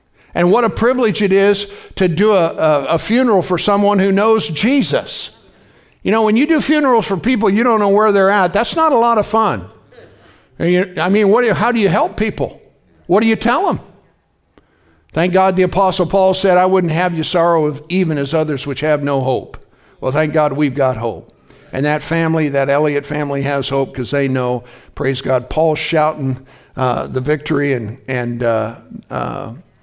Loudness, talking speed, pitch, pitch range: -15 LUFS, 205 wpm, 165 Hz, 140-205 Hz